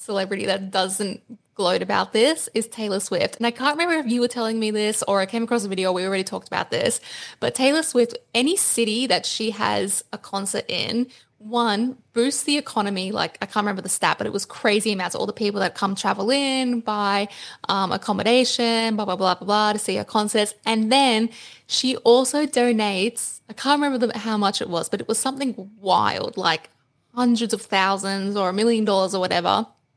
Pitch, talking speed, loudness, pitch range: 220 Hz, 210 wpm, -22 LUFS, 200-240 Hz